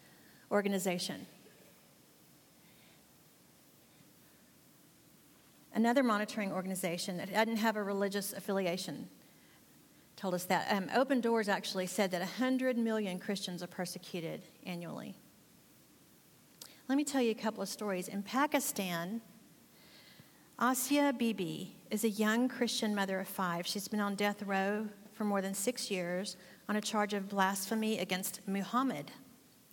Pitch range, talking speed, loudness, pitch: 190-225 Hz, 125 wpm, -35 LUFS, 205 Hz